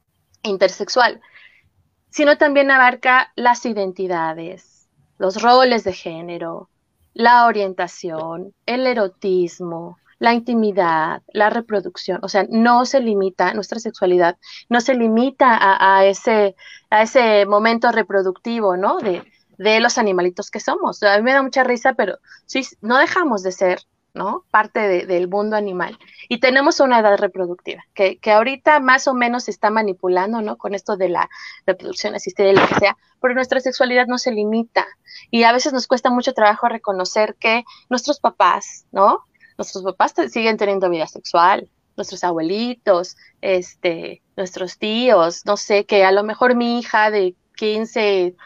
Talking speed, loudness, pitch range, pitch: 155 wpm, -17 LUFS, 190-240 Hz, 210 Hz